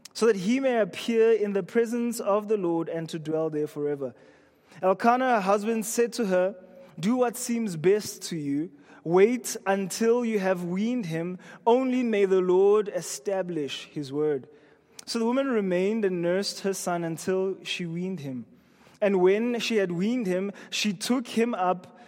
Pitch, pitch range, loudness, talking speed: 195 Hz, 175-230 Hz, -26 LUFS, 170 wpm